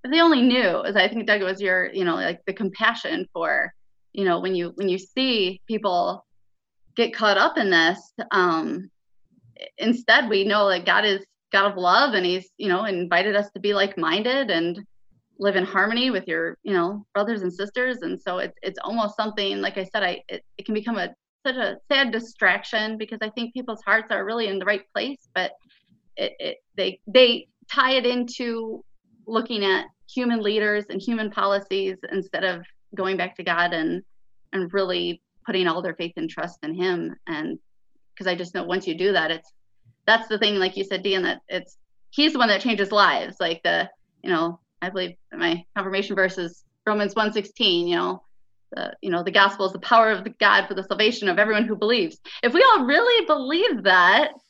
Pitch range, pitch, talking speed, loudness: 180-225 Hz, 200 Hz, 205 wpm, -22 LUFS